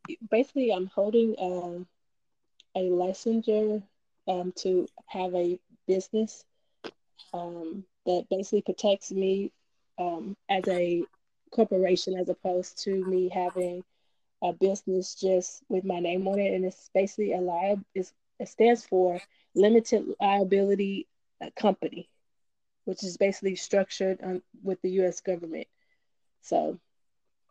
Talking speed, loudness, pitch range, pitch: 120 wpm, -28 LUFS, 180-200 Hz, 190 Hz